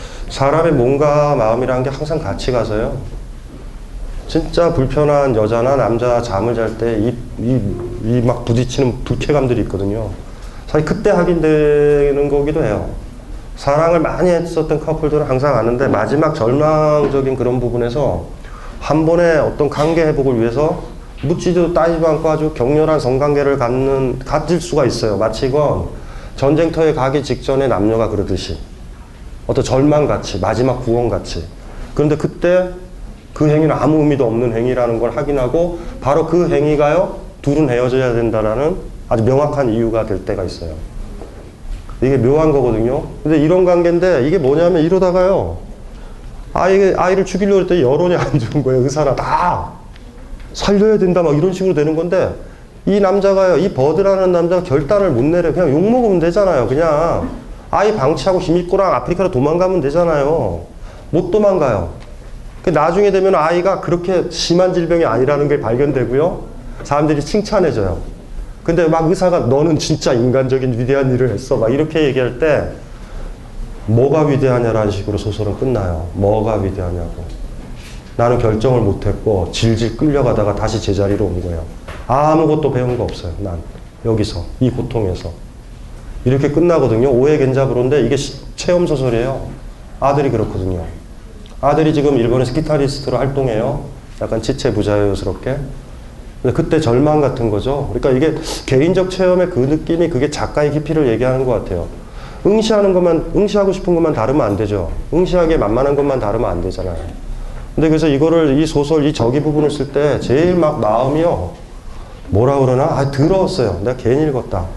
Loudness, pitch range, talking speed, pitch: -15 LUFS, 115-160 Hz, 345 characters per minute, 135 Hz